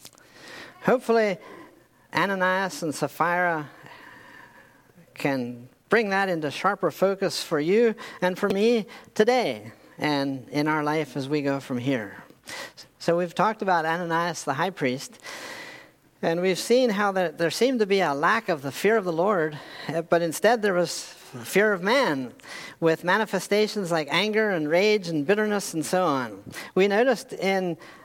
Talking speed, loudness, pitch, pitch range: 150 wpm, -24 LUFS, 180 Hz, 155-205 Hz